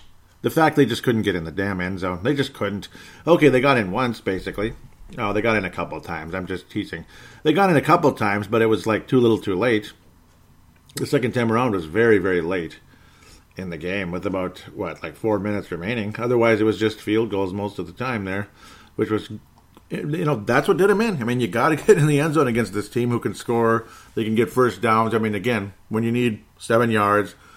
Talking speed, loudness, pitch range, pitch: 240 wpm, -21 LUFS, 95-120 Hz, 110 Hz